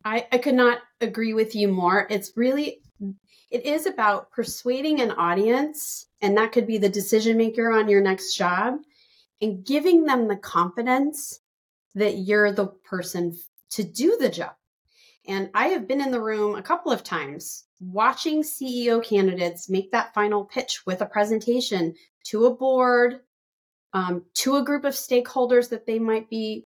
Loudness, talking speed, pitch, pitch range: -23 LUFS, 165 wpm, 225 Hz, 200-255 Hz